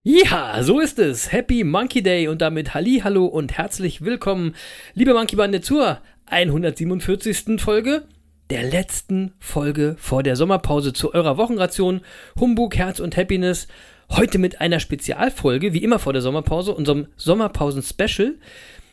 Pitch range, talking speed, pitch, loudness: 155-220 Hz, 140 wpm, 185 Hz, -20 LUFS